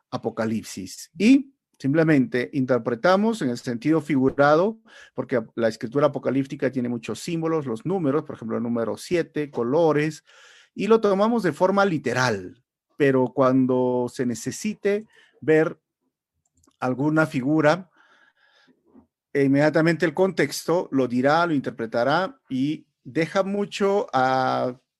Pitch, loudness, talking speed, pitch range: 150 Hz, -23 LUFS, 115 wpm, 125-175 Hz